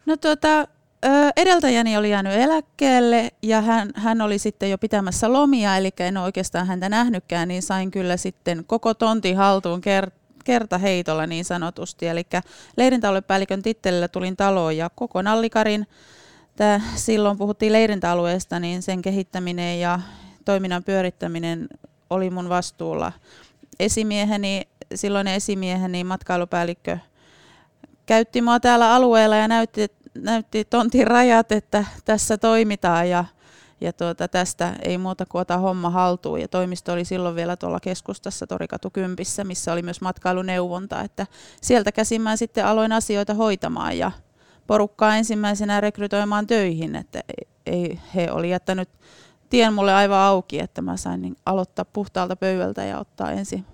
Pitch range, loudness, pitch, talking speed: 180-220 Hz, -21 LUFS, 195 Hz, 135 wpm